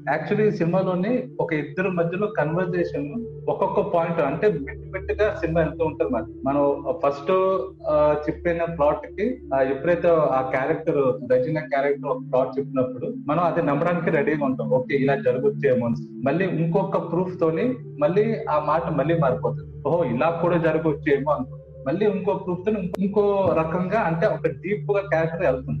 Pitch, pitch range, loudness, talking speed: 165 Hz, 140-190 Hz, -23 LUFS, 145 wpm